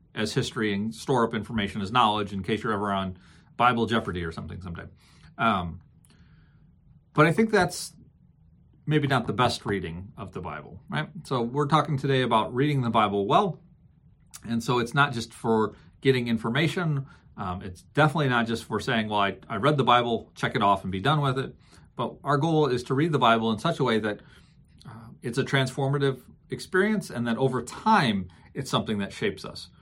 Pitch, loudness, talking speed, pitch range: 120 Hz, -26 LUFS, 195 wpm, 105-140 Hz